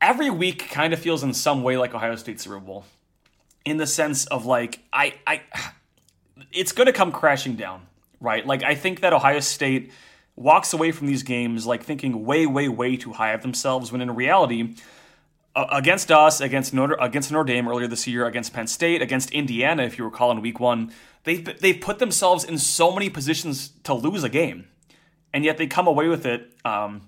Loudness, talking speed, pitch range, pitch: -22 LUFS, 200 wpm, 120-160 Hz, 135 Hz